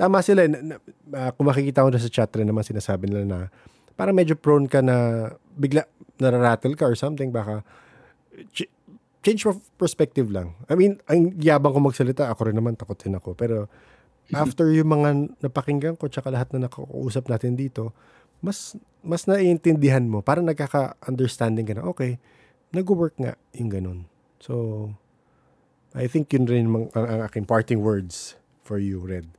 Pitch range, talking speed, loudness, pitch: 110-150 Hz, 165 wpm, -23 LUFS, 130 Hz